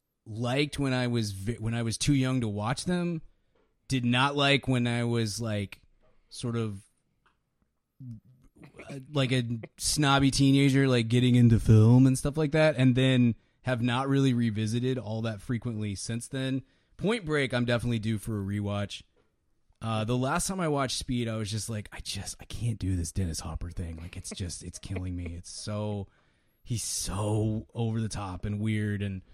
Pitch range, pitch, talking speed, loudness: 105-130 Hz, 115 Hz, 180 wpm, -28 LUFS